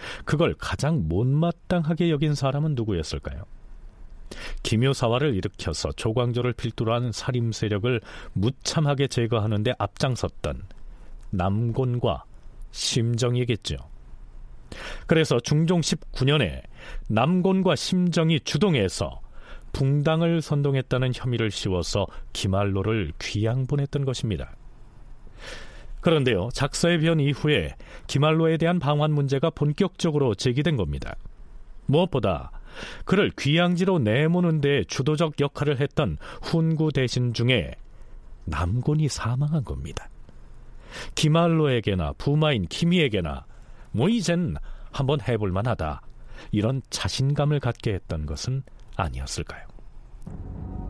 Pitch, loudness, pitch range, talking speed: 125 Hz, -24 LUFS, 100-155 Hz, 260 characters per minute